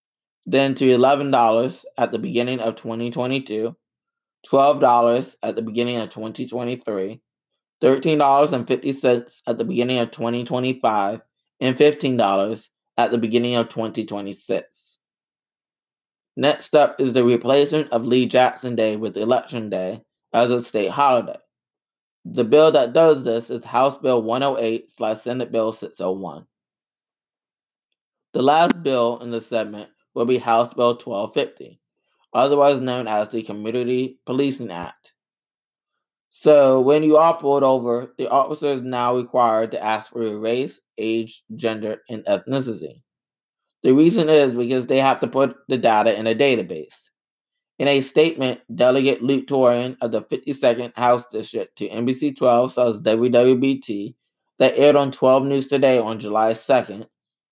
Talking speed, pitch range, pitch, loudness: 135 wpm, 115-135 Hz, 120 Hz, -20 LUFS